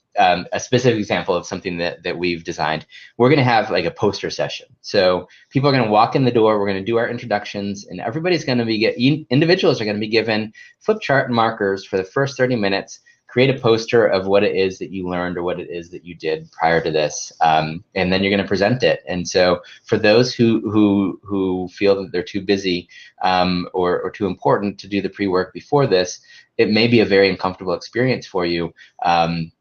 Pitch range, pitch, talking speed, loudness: 90-115 Hz, 100 Hz, 230 wpm, -19 LUFS